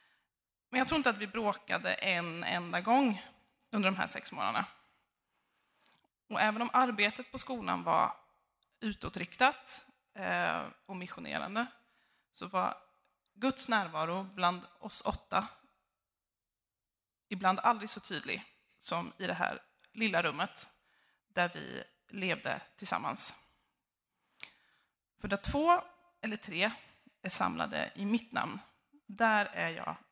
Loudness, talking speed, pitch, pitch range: -33 LUFS, 120 wpm, 220 Hz, 190-255 Hz